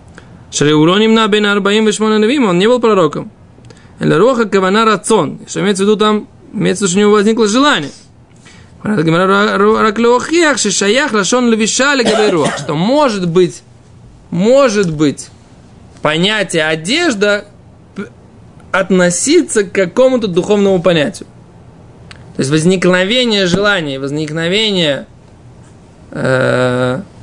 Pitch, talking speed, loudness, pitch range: 205 Hz, 110 wpm, -12 LUFS, 180-225 Hz